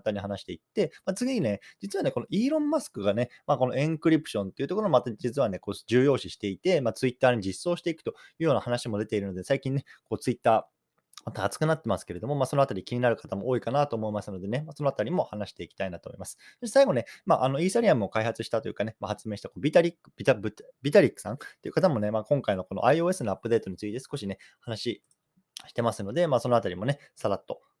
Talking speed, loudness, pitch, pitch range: 550 characters per minute, -28 LUFS, 125 Hz, 105-155 Hz